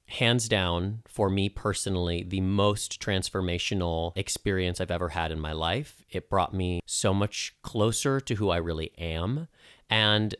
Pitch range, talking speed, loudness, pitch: 85-110 Hz, 155 wpm, -28 LUFS, 95 Hz